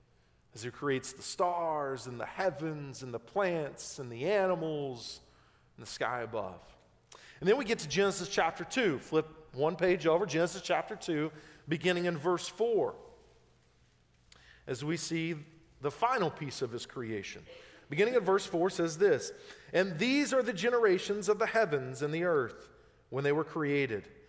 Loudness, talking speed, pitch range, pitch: -32 LUFS, 165 wpm, 140-200 Hz, 165 Hz